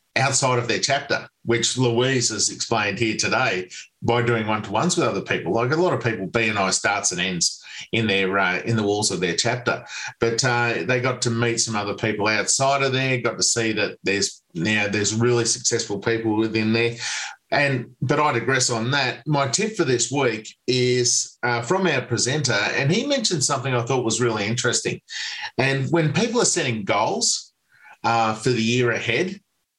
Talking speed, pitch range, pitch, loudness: 190 wpm, 110-135 Hz, 120 Hz, -21 LUFS